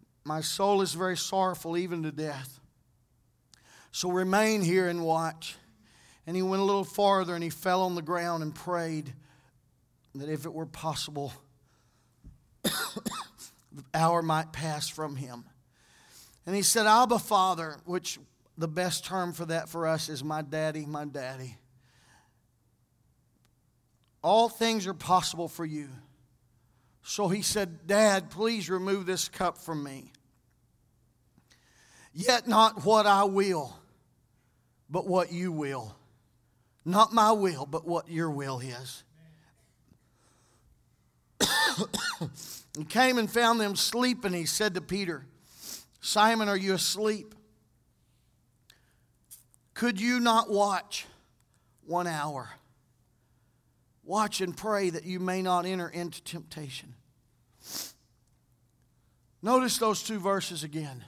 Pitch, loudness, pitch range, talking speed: 165 Hz, -28 LUFS, 130-190 Hz, 120 wpm